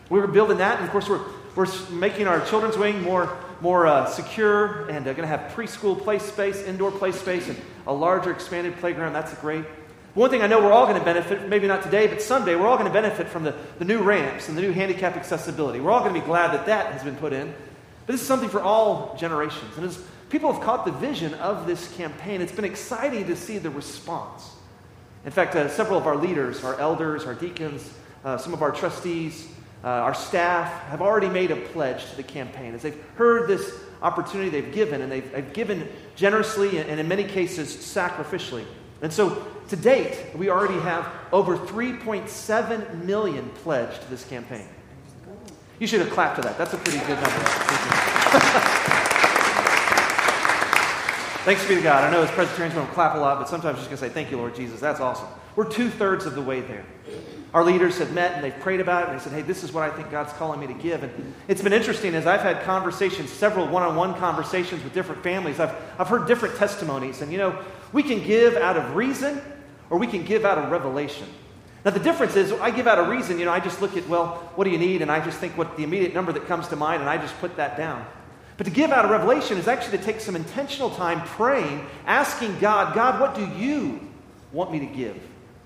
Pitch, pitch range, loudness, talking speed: 175 Hz, 155-205 Hz, -23 LUFS, 230 wpm